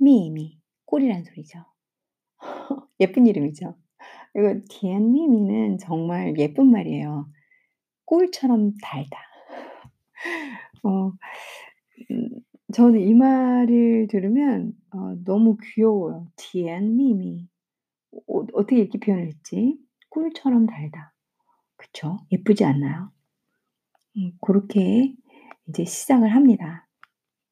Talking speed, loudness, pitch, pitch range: 200 characters per minute, -21 LUFS, 215 Hz, 180-250 Hz